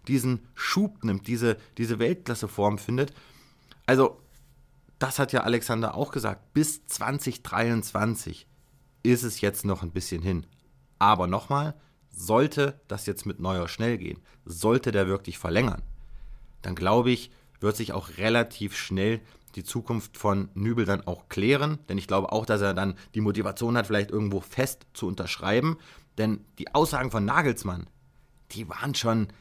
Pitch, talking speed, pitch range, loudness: 110 Hz, 150 wpm, 100-130 Hz, -27 LUFS